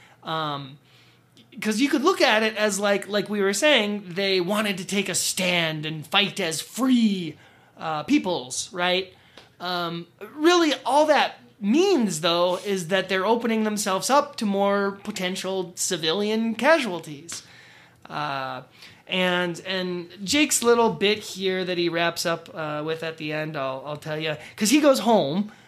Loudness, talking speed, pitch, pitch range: -23 LUFS, 155 wpm, 190 Hz, 170-215 Hz